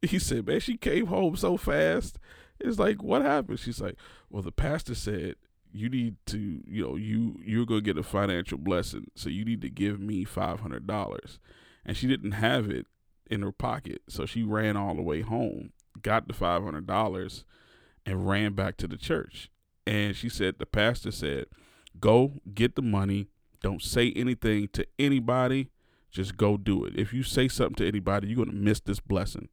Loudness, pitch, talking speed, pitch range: -29 LUFS, 105 Hz, 185 wpm, 100-120 Hz